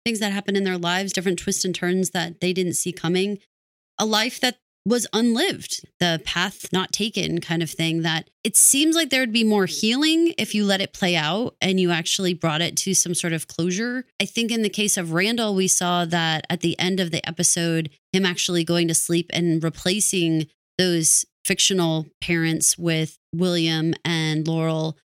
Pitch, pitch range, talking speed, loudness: 180 Hz, 165-200 Hz, 195 wpm, -21 LUFS